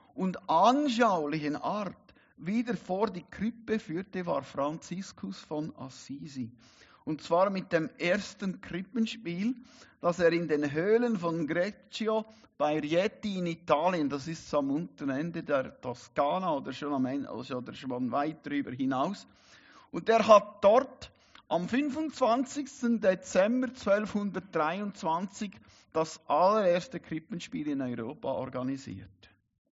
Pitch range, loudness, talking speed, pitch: 145-215 Hz, -30 LUFS, 120 wpm, 175 Hz